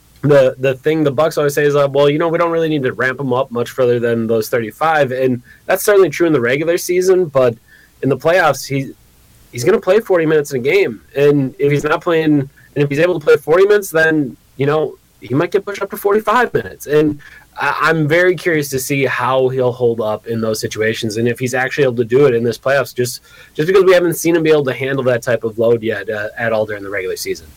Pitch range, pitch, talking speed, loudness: 125-170 Hz, 145 Hz, 260 wpm, -15 LUFS